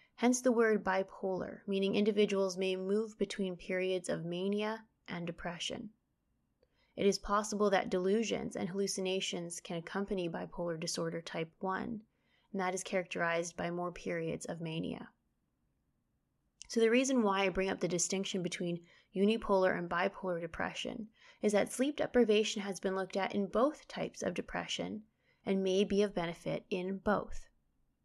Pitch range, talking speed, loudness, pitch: 180-210 Hz, 150 wpm, -35 LUFS, 195 Hz